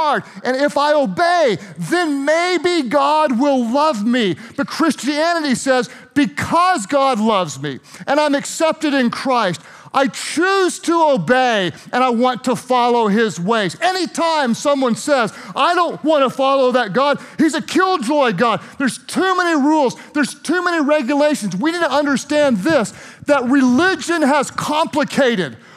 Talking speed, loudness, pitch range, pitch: 150 wpm, -16 LUFS, 245-310 Hz, 280 Hz